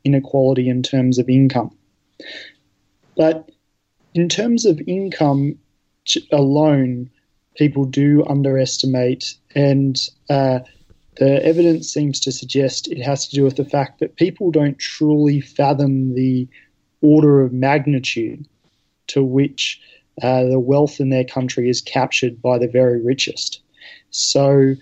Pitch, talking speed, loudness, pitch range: 135 Hz, 125 wpm, -17 LUFS, 130-145 Hz